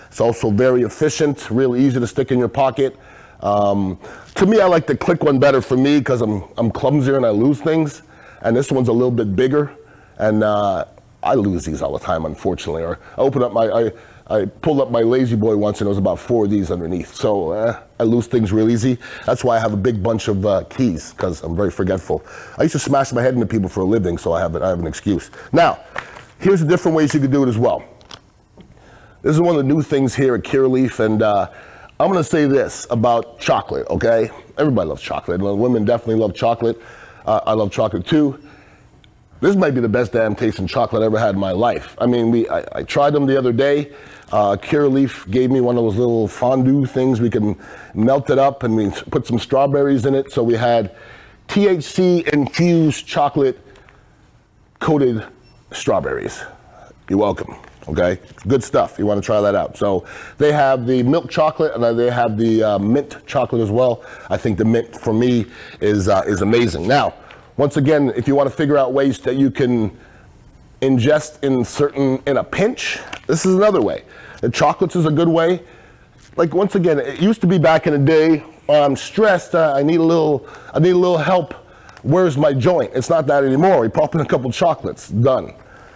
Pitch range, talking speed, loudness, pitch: 110-145 Hz, 215 wpm, -17 LUFS, 130 Hz